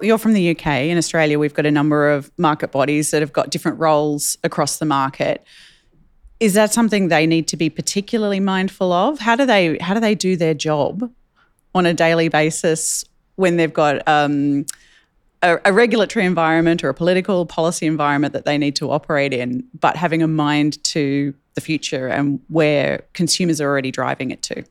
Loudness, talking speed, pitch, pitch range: -18 LUFS, 190 wpm, 160 Hz, 150-180 Hz